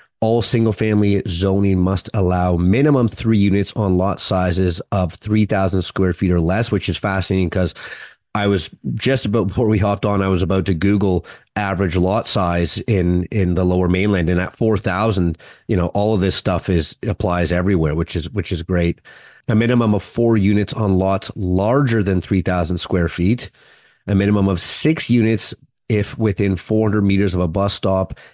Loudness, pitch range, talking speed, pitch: -18 LUFS, 90-110 Hz, 180 wpm, 95 Hz